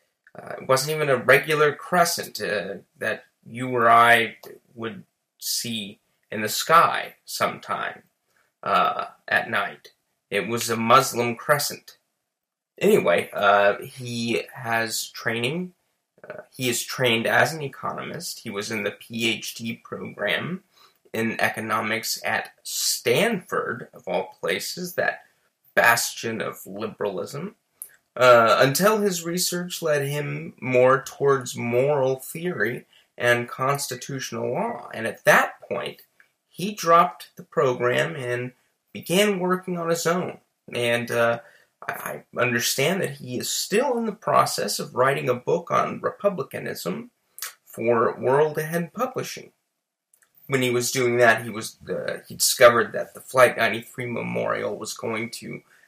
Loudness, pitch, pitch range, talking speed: -23 LUFS, 125 Hz, 115-165 Hz, 130 wpm